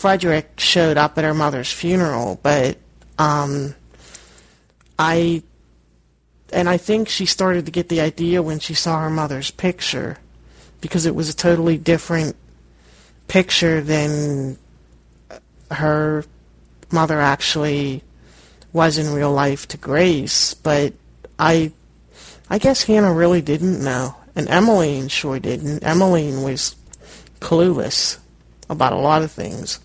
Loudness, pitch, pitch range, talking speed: -18 LUFS, 150 Hz, 125-170 Hz, 125 wpm